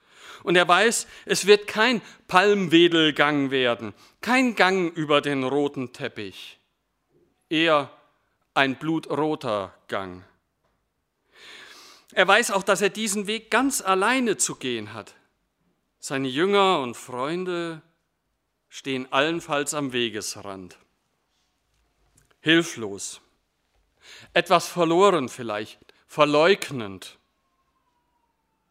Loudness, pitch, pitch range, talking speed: -22 LUFS, 155 Hz, 125-195 Hz, 90 wpm